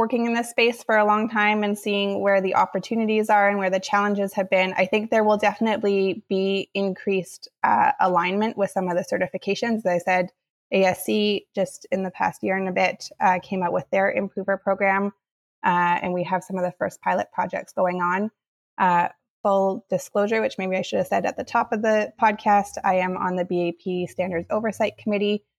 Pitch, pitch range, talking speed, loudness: 195 Hz, 185-215 Hz, 205 wpm, -23 LUFS